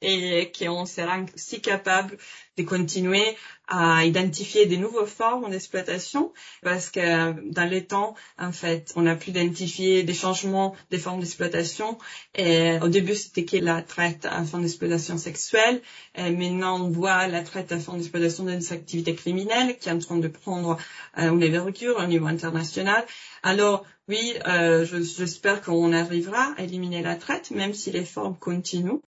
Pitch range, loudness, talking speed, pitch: 170-195 Hz, -25 LUFS, 160 wpm, 180 Hz